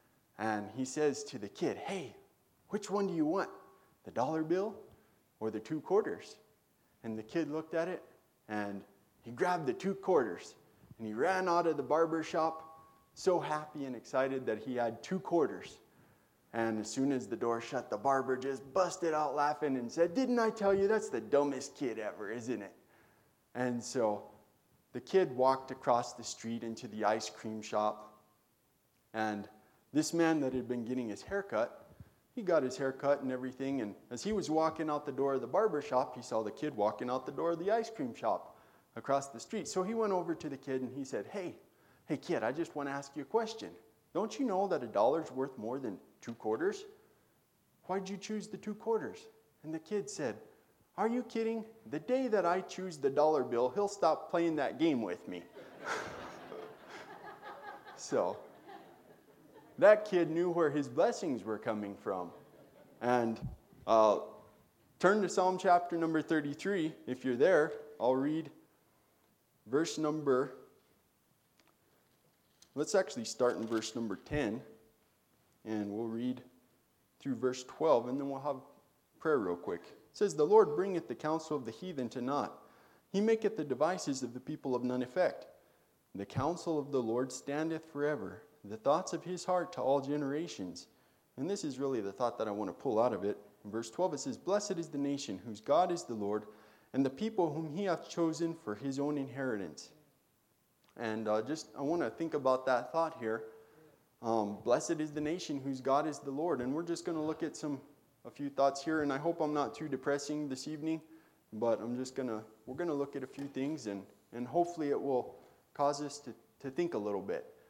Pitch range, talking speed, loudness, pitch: 120-170 Hz, 195 wpm, -35 LUFS, 145 Hz